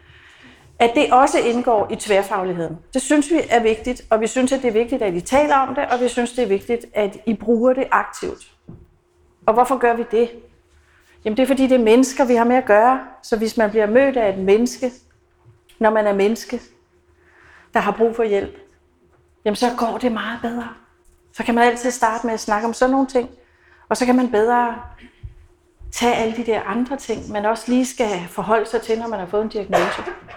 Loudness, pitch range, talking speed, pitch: -19 LUFS, 215-250 Hz, 215 wpm, 235 Hz